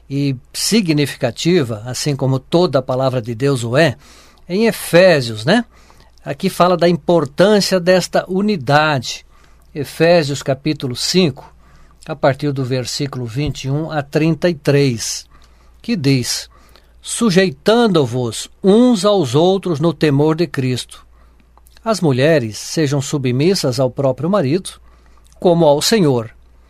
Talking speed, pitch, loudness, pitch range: 115 wpm, 145 Hz, -16 LUFS, 130-175 Hz